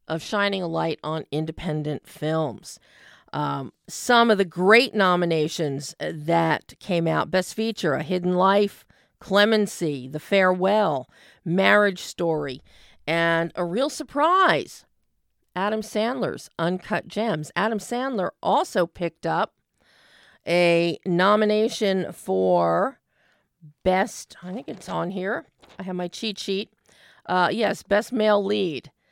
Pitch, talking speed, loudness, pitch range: 185 Hz, 120 wpm, -23 LUFS, 165-210 Hz